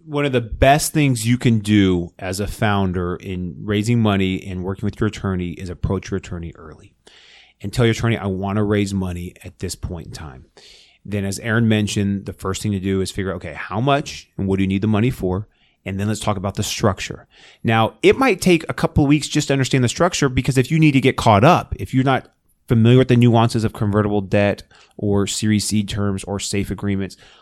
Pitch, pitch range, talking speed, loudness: 105 Hz, 95-120 Hz, 230 wpm, -19 LUFS